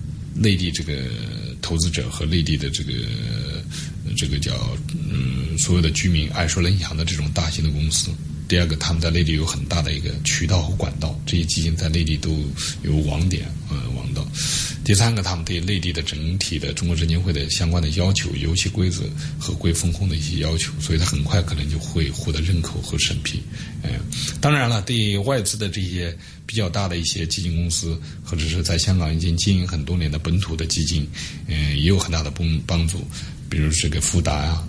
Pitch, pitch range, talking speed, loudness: 85 Hz, 80-90 Hz, 305 characters per minute, -22 LUFS